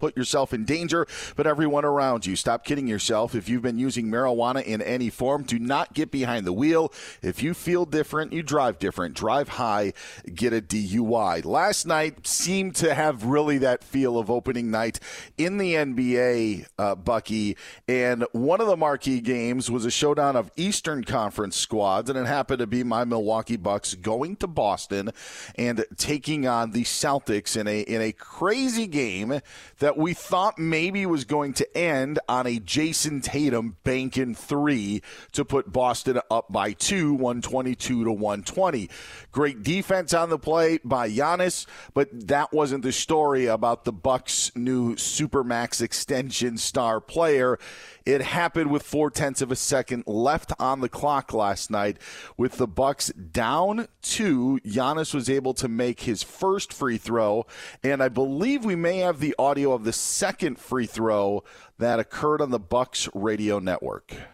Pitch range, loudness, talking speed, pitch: 115-150 Hz, -25 LUFS, 170 wpm, 130 Hz